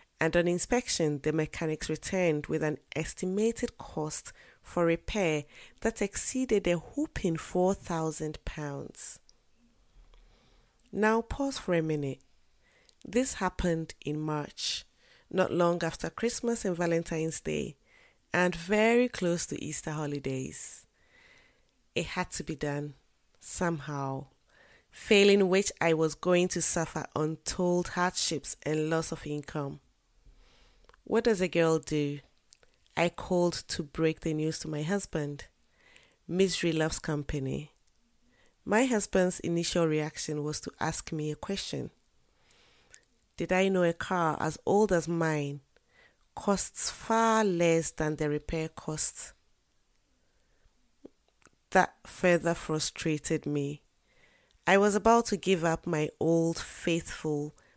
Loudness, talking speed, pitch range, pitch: -30 LUFS, 120 wpm, 155-185 Hz, 165 Hz